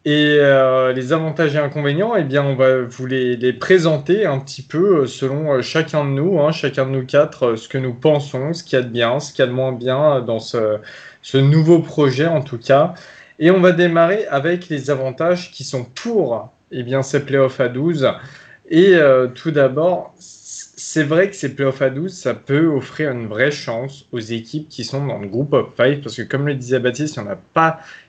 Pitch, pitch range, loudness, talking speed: 140 Hz, 130-160 Hz, -17 LUFS, 225 wpm